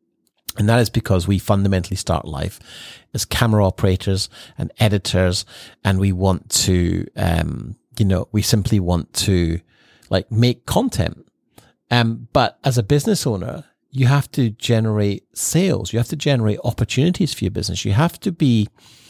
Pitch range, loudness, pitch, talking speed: 95-120 Hz, -19 LUFS, 105 Hz, 155 wpm